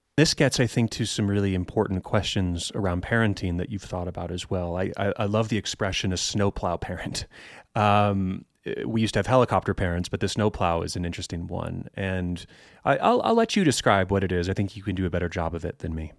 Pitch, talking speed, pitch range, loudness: 100 Hz, 230 wpm, 90-105 Hz, -26 LUFS